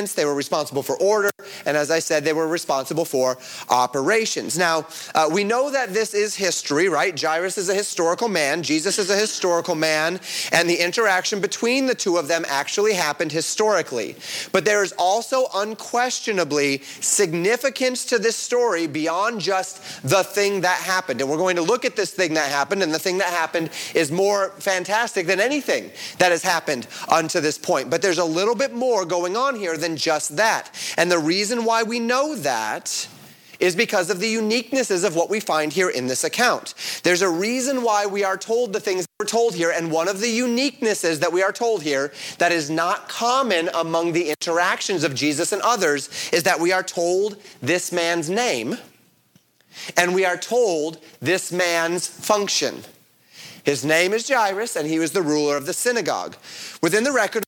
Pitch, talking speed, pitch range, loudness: 185 Hz, 190 wpm, 165-215 Hz, -21 LUFS